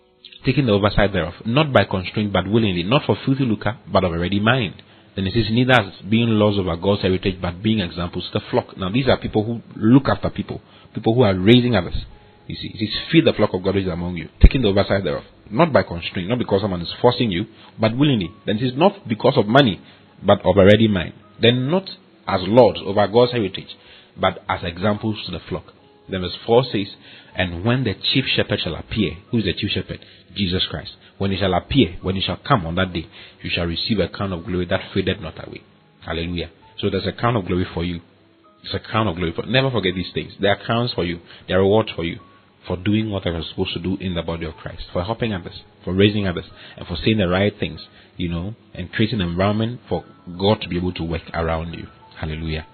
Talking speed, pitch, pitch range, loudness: 240 wpm, 100 Hz, 90-110 Hz, -20 LUFS